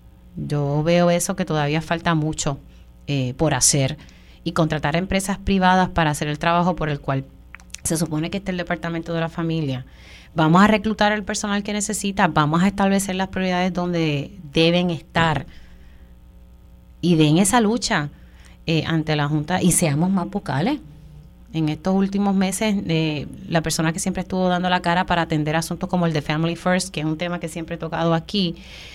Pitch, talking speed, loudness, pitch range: 165 Hz, 180 wpm, -21 LUFS, 155-185 Hz